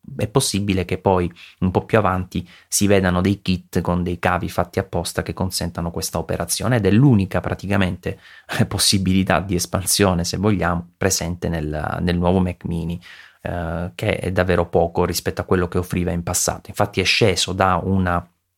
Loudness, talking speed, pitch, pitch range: -20 LUFS, 170 wpm, 90 Hz, 85-95 Hz